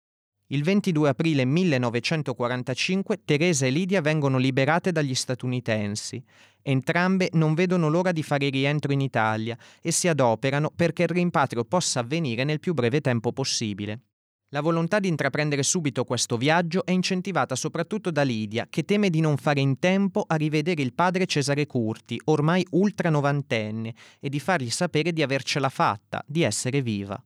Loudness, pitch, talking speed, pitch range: -24 LUFS, 145 Hz, 155 wpm, 125-170 Hz